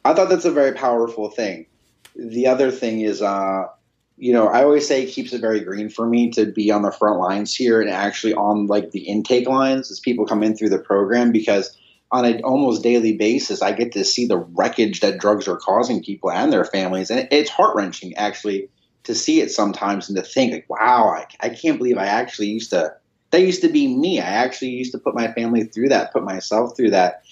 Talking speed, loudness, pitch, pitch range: 230 wpm, -19 LUFS, 115 Hz, 105-130 Hz